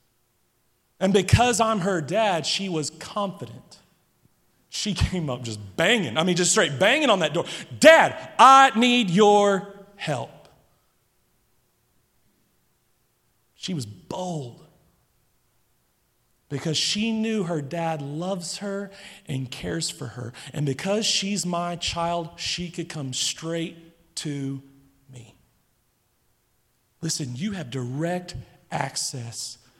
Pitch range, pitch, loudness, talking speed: 140-200 Hz, 170 Hz, -23 LUFS, 115 wpm